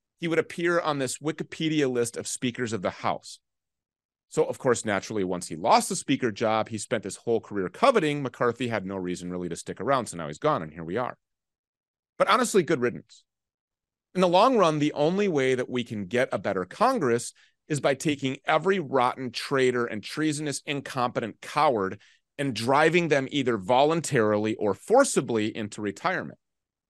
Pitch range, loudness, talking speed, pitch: 110-155 Hz, -26 LUFS, 180 wpm, 130 Hz